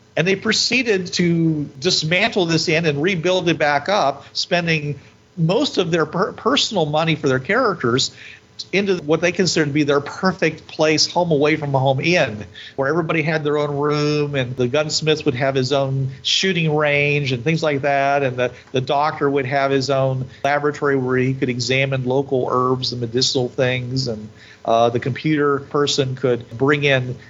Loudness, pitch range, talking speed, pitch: -18 LUFS, 130-160 Hz, 180 wpm, 145 Hz